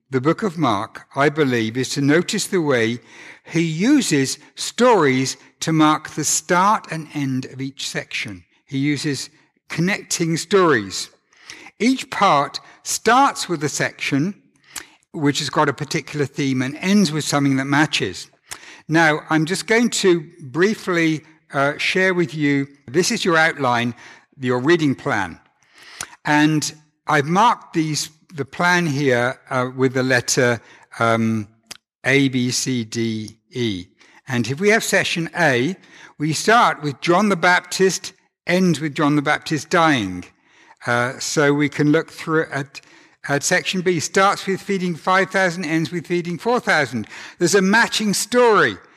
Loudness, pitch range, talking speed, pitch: -19 LUFS, 135-180 Hz, 150 wpm, 155 Hz